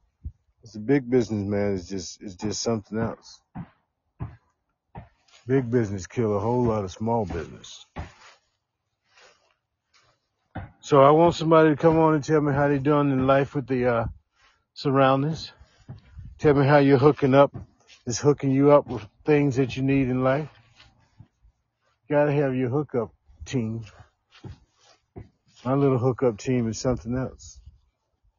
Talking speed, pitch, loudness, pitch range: 140 wpm, 125 Hz, -23 LUFS, 105-140 Hz